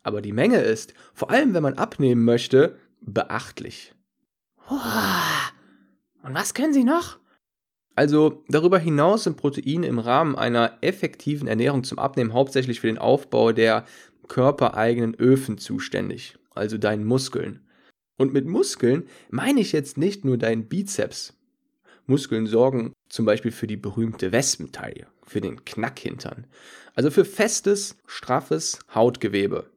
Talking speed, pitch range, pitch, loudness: 130 wpm, 115-180 Hz, 135 Hz, -23 LUFS